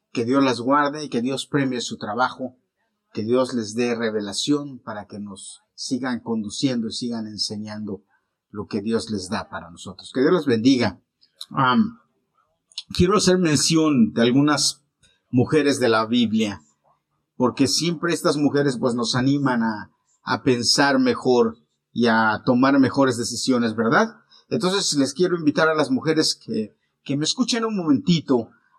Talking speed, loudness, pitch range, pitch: 155 wpm, -21 LUFS, 110-150 Hz, 130 Hz